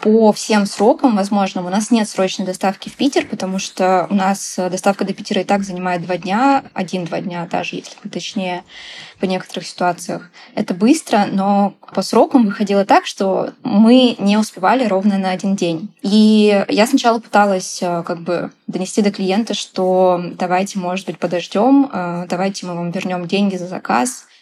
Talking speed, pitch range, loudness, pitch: 165 wpm, 185-215 Hz, -16 LUFS, 195 Hz